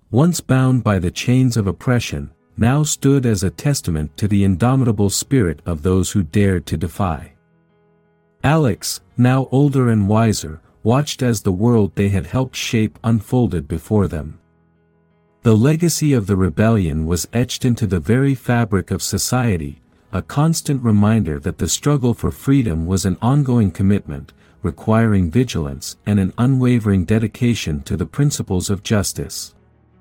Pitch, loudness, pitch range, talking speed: 105 Hz, -18 LUFS, 85-125 Hz, 150 wpm